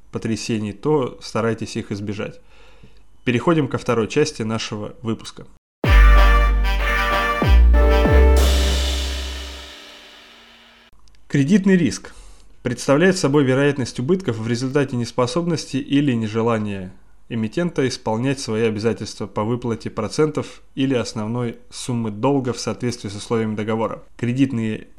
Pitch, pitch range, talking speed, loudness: 115 Hz, 105-130 Hz, 95 wpm, -20 LUFS